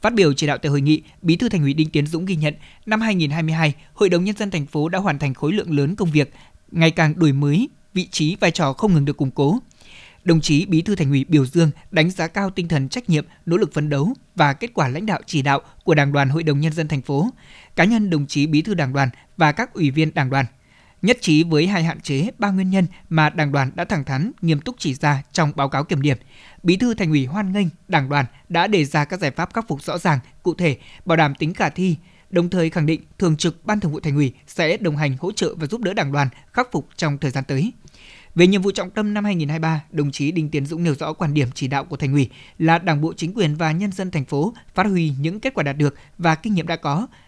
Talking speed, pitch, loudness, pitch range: 270 wpm, 160 Hz, -20 LUFS, 145-185 Hz